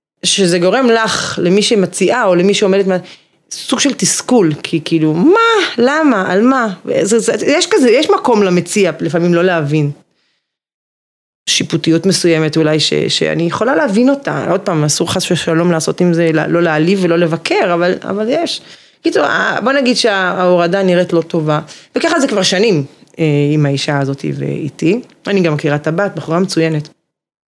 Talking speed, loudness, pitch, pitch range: 155 wpm, -13 LUFS, 180 Hz, 160-210 Hz